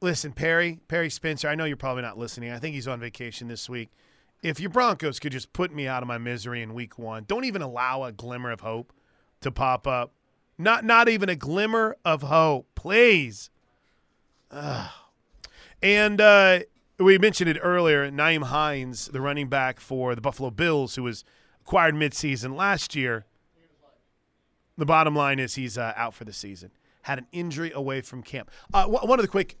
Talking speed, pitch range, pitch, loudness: 190 wpm, 125-170 Hz, 140 Hz, -24 LUFS